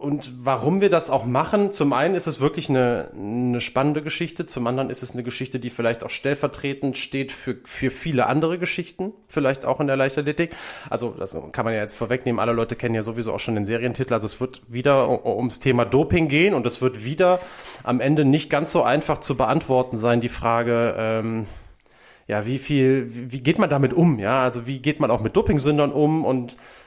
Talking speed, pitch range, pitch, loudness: 210 wpm, 120-150 Hz, 130 Hz, -22 LUFS